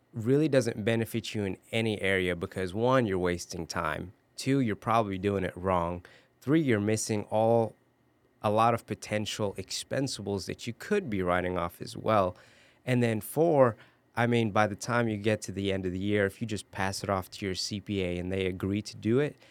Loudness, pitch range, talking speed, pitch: -29 LUFS, 95-115 Hz, 205 wpm, 105 Hz